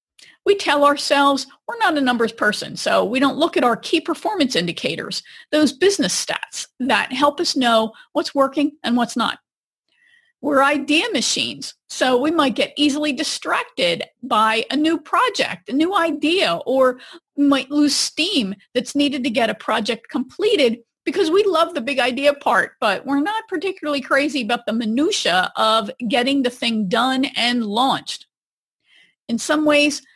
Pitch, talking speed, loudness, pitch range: 280 Hz, 160 wpm, -19 LUFS, 245-310 Hz